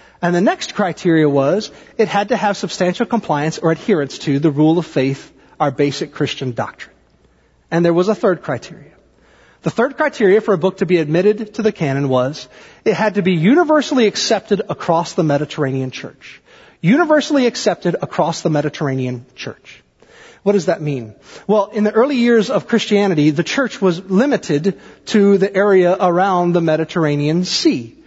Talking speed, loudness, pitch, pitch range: 170 wpm, -16 LUFS, 185 Hz, 155-210 Hz